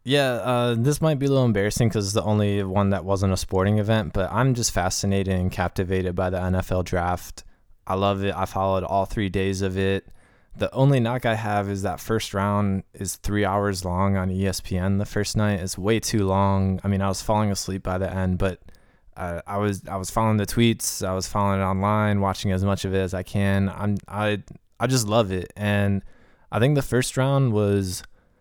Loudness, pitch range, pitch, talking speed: -24 LUFS, 95-105 Hz, 100 Hz, 220 wpm